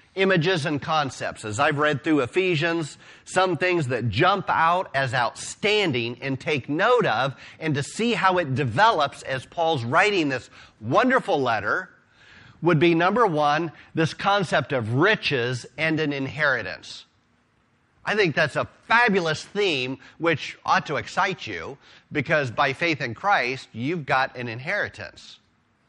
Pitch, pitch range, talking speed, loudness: 155 Hz, 135-175 Hz, 145 wpm, -23 LUFS